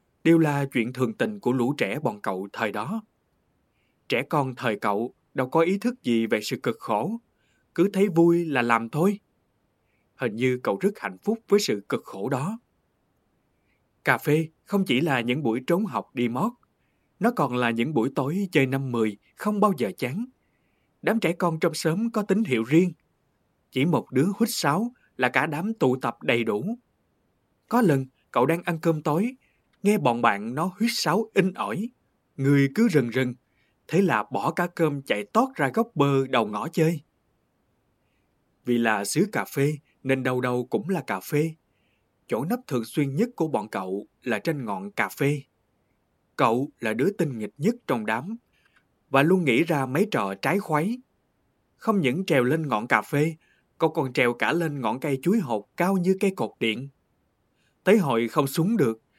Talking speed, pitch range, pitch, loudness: 190 wpm, 125-200 Hz, 160 Hz, -25 LUFS